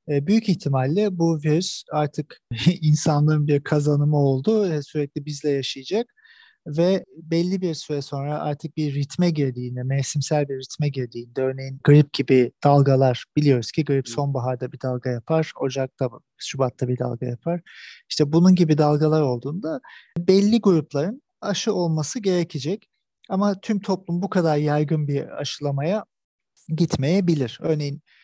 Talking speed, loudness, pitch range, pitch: 130 wpm, -22 LUFS, 135-170 Hz, 150 Hz